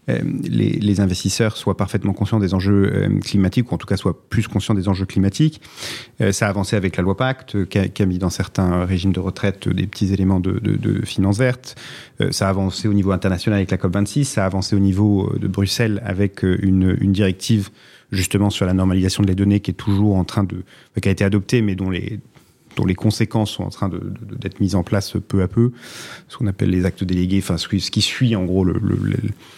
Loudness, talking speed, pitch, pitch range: -19 LUFS, 250 wpm, 100 Hz, 95-110 Hz